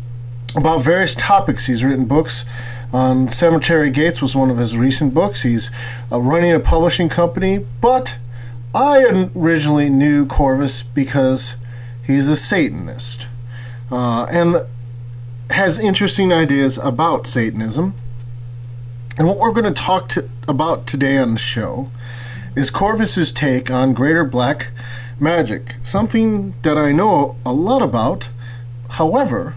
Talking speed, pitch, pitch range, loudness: 130 wpm, 130 Hz, 120-160 Hz, -16 LUFS